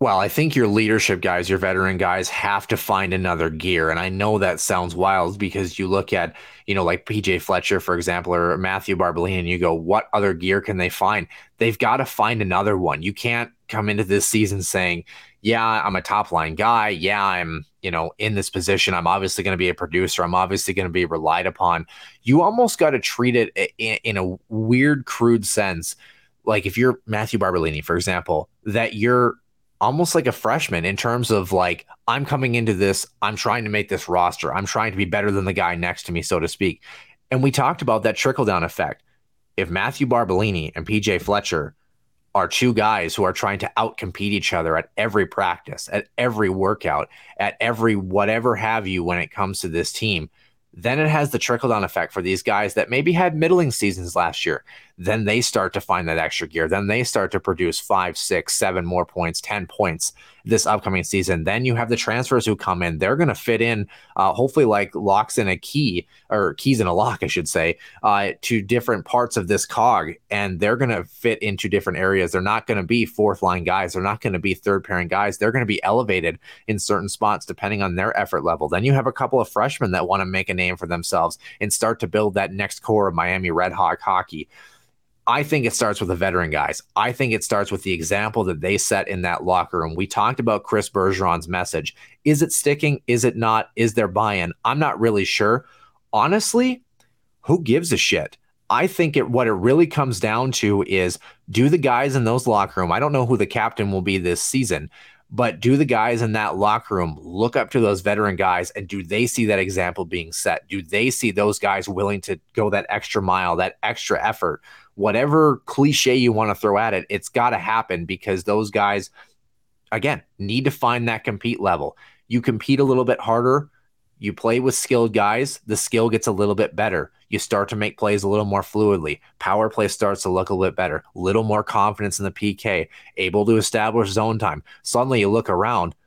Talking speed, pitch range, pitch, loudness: 220 wpm, 95-120 Hz, 105 Hz, -21 LUFS